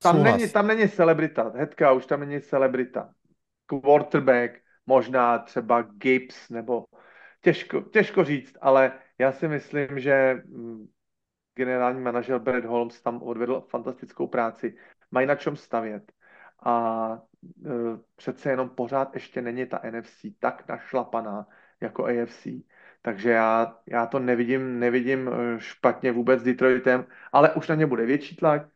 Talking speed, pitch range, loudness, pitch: 135 wpm, 120-140 Hz, -24 LUFS, 130 Hz